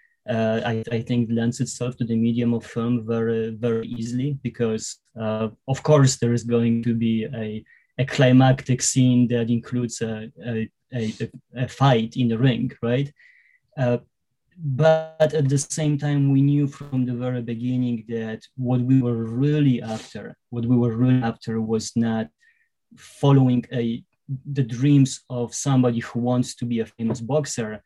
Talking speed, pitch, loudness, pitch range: 165 wpm, 120 Hz, -22 LUFS, 115-135 Hz